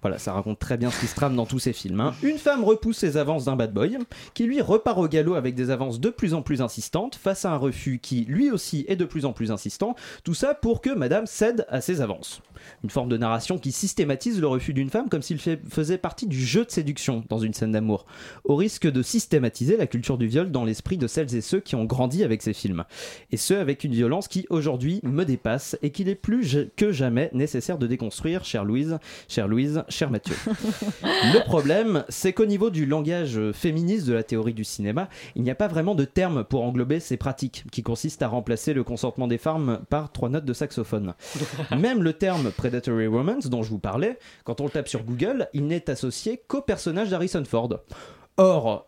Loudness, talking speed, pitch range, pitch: -25 LUFS, 225 wpm, 120-185 Hz, 145 Hz